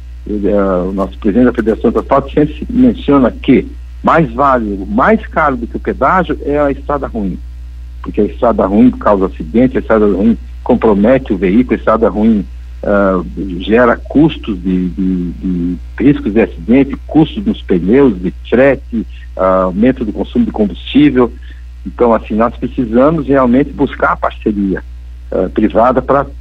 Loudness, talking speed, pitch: -12 LUFS, 155 wpm, 100 Hz